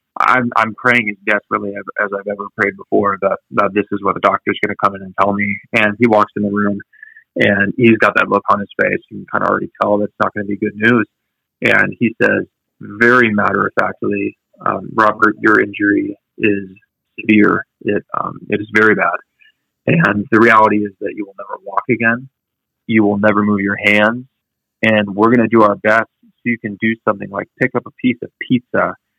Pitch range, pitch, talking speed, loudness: 100-115 Hz, 105 Hz, 220 wpm, -15 LUFS